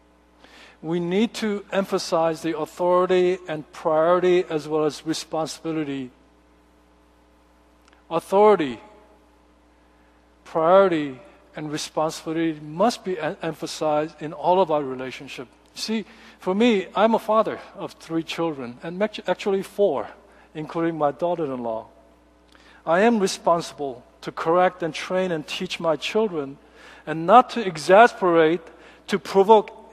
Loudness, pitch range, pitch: -22 LUFS, 140-185 Hz, 165 Hz